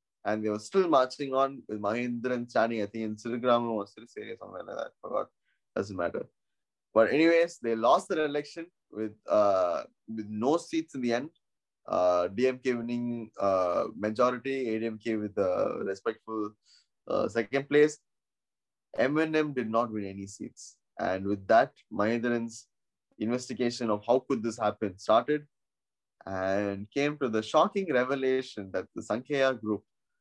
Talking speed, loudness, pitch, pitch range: 150 wpm, -29 LUFS, 115 Hz, 105-135 Hz